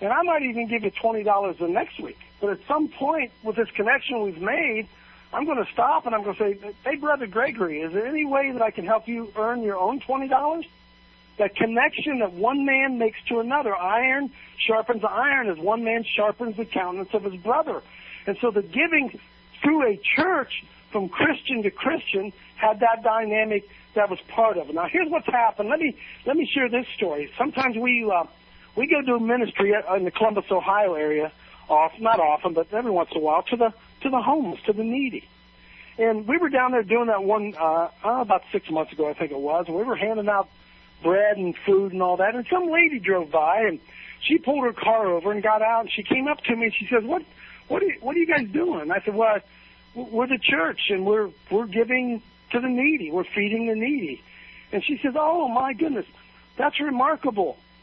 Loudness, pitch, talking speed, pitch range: -23 LUFS, 225 Hz, 220 wpm, 200-270 Hz